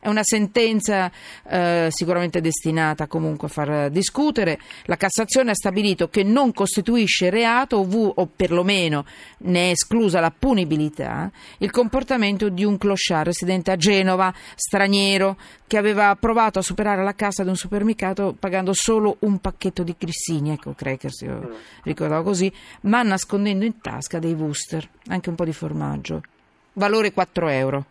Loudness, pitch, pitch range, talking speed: -21 LUFS, 190 Hz, 170-210 Hz, 150 wpm